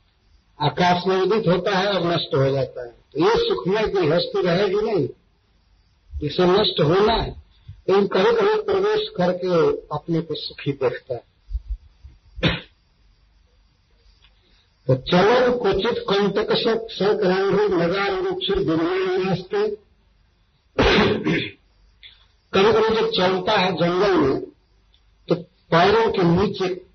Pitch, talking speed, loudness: 185 Hz, 120 wpm, -20 LUFS